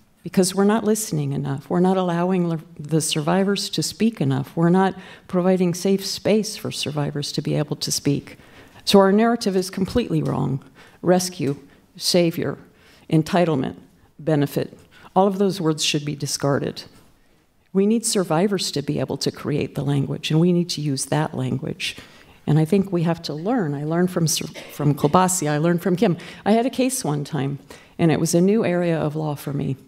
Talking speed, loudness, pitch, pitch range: 185 wpm, -21 LUFS, 170 Hz, 145-190 Hz